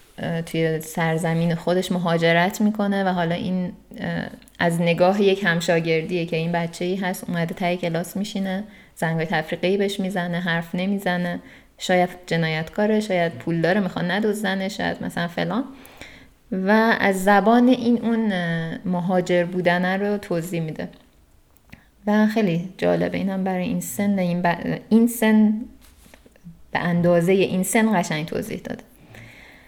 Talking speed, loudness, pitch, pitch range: 135 wpm, -22 LUFS, 180 Hz, 170-205 Hz